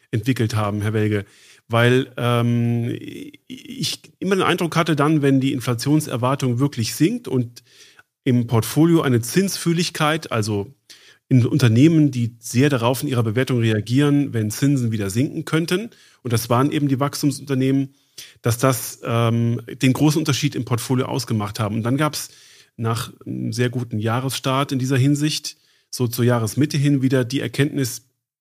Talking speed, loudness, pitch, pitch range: 150 wpm, -20 LUFS, 130 Hz, 120-145 Hz